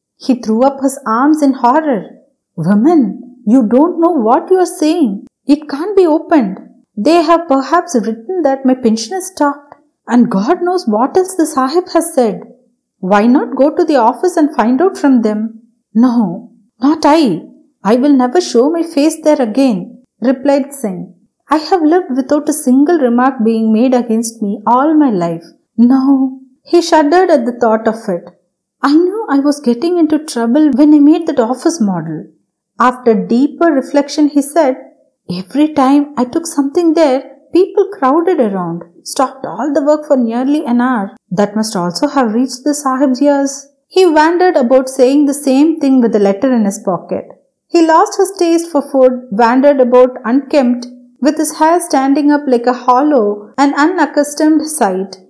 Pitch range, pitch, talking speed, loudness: 240-305 Hz, 270 Hz, 175 wpm, -12 LUFS